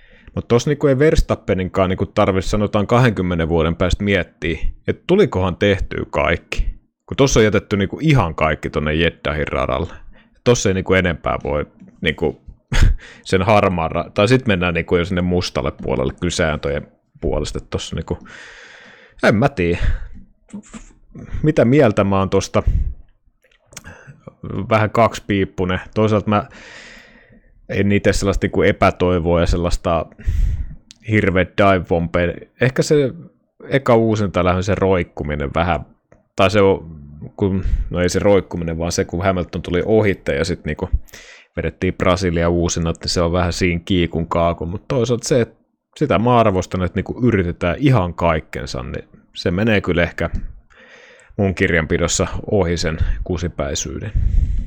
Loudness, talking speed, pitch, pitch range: -18 LUFS, 140 wpm, 90 Hz, 85-105 Hz